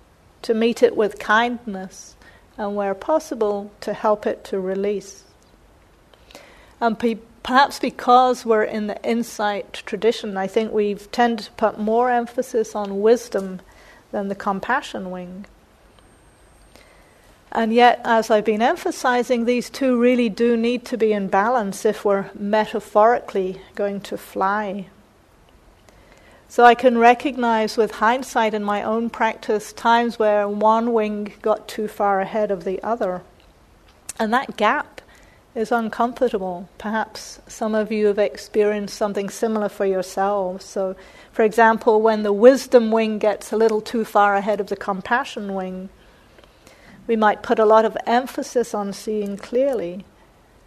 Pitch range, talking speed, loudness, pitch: 200-235 Hz, 140 wpm, -20 LUFS, 215 Hz